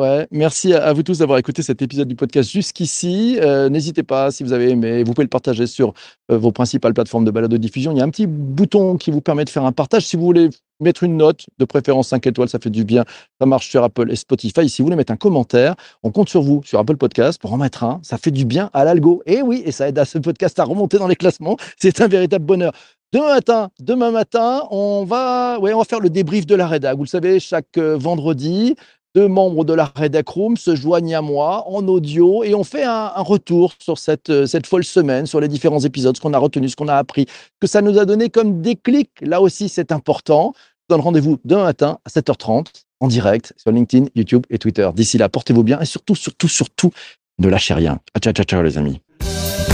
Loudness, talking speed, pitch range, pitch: -16 LUFS, 245 wpm, 130-185 Hz, 155 Hz